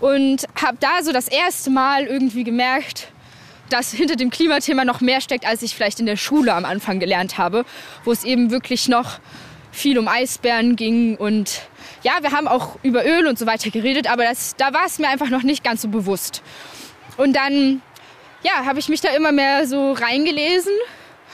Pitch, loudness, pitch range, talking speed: 260 Hz, -18 LUFS, 235-285 Hz, 195 wpm